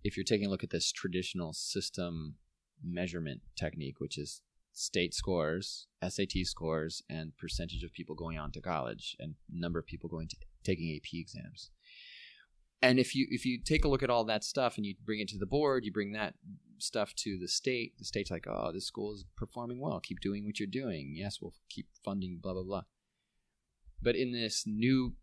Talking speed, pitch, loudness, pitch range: 200 wpm, 95 Hz, -36 LUFS, 85-110 Hz